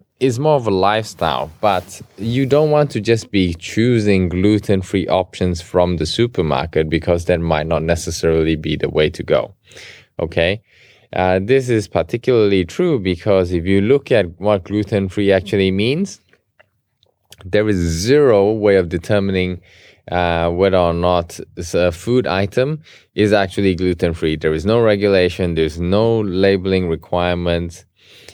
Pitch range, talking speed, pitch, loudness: 85-105 Hz, 150 wpm, 95 Hz, -17 LUFS